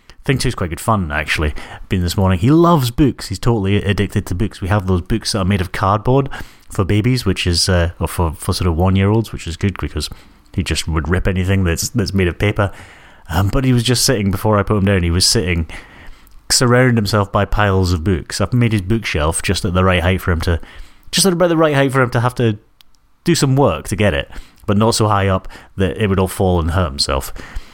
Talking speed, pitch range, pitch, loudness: 255 wpm, 90-115 Hz, 100 Hz, -16 LUFS